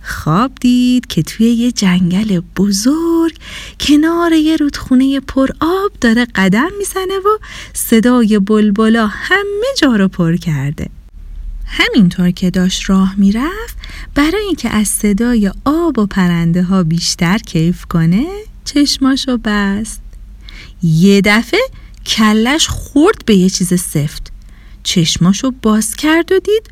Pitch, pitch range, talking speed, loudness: 220 Hz, 185-290 Hz, 120 wpm, -13 LUFS